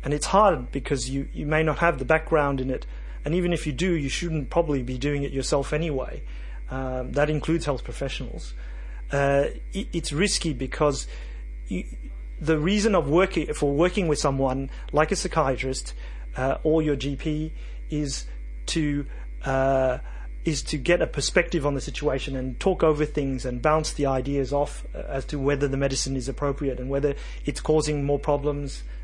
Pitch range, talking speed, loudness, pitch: 130-155 Hz, 175 wpm, -25 LUFS, 145 Hz